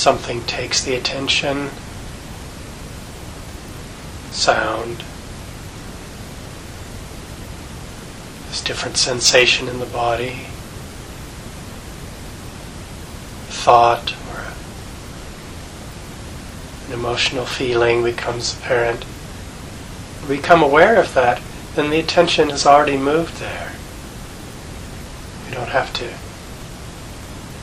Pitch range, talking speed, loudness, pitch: 120-140 Hz, 75 wpm, -17 LUFS, 125 Hz